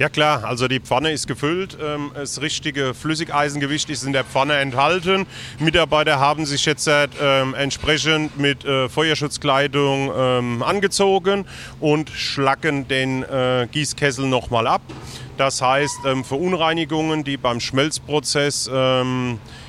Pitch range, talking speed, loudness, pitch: 130-155 Hz, 130 wpm, -19 LUFS, 140 Hz